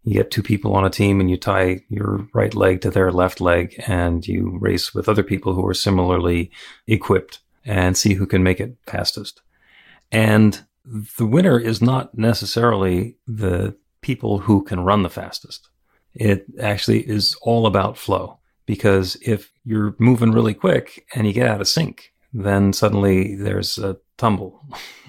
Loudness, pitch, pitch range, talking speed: -19 LUFS, 100 Hz, 95-110 Hz, 165 wpm